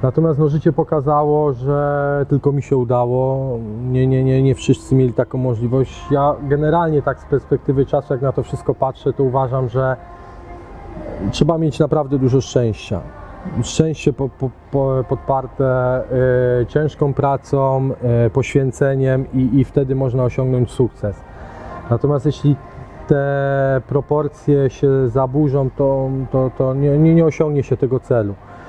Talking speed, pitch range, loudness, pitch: 140 wpm, 130-145 Hz, -17 LUFS, 135 Hz